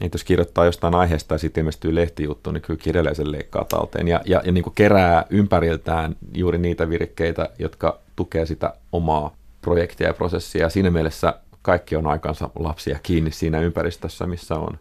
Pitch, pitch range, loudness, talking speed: 85 Hz, 80-90 Hz, -21 LUFS, 170 wpm